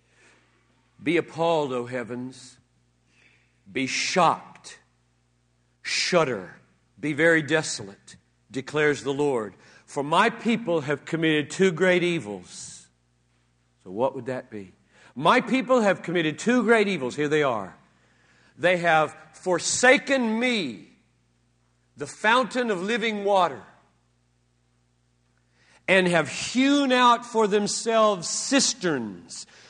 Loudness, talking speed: -23 LUFS, 105 wpm